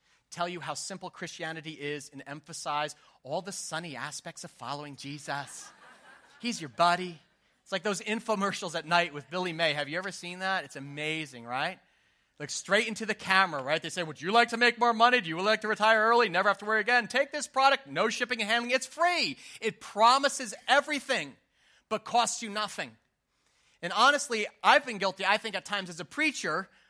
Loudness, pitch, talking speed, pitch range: -28 LUFS, 195 Hz, 200 wpm, 165-235 Hz